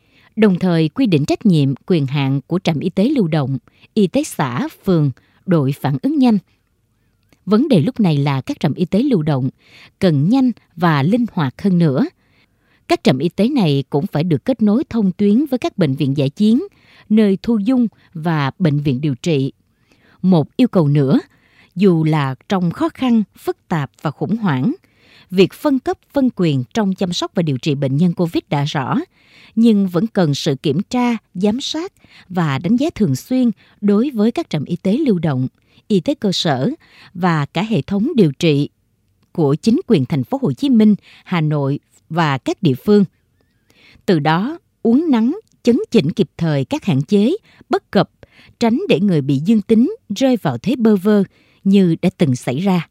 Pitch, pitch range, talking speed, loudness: 180 Hz, 145-225 Hz, 195 wpm, -17 LUFS